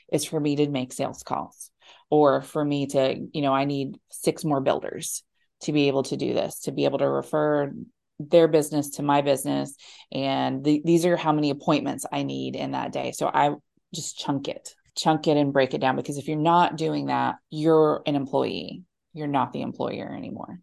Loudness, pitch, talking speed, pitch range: -25 LUFS, 145 Hz, 205 wpm, 135-155 Hz